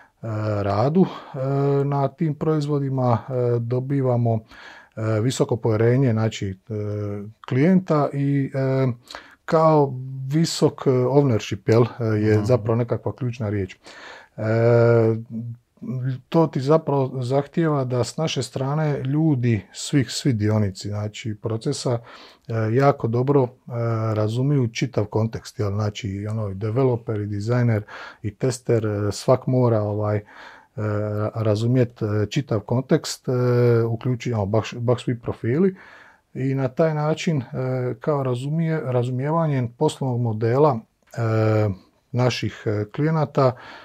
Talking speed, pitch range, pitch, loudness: 90 wpm, 110-140 Hz, 125 Hz, -22 LUFS